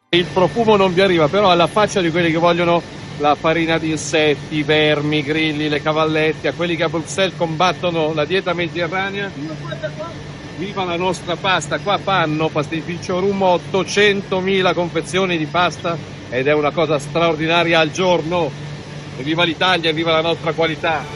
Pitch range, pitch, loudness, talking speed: 155-180 Hz, 165 Hz, -17 LUFS, 160 wpm